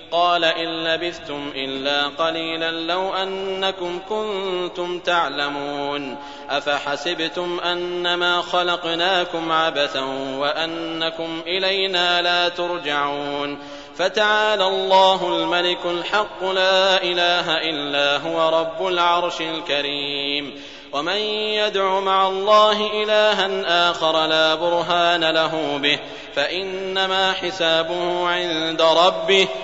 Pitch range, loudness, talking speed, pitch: 160-190 Hz, -20 LUFS, 85 wpm, 175 Hz